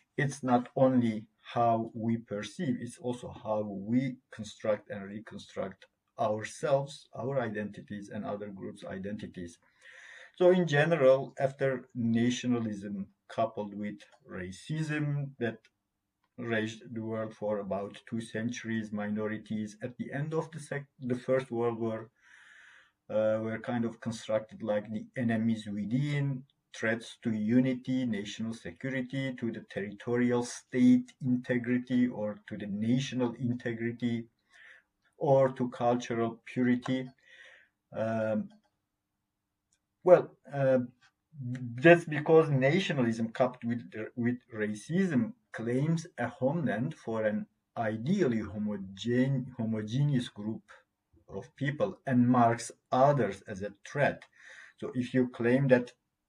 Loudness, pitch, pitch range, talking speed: -31 LUFS, 120 Hz, 110-130 Hz, 115 wpm